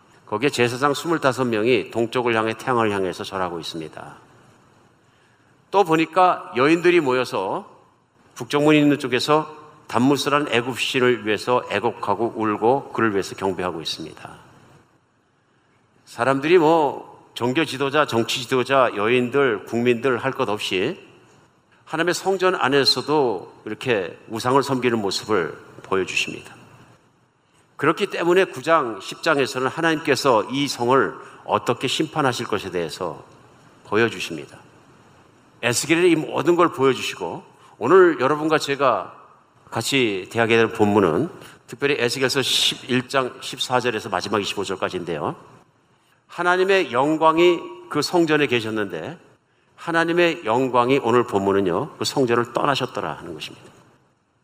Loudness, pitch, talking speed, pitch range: -21 LUFS, 130 Hz, 285 characters per minute, 120-160 Hz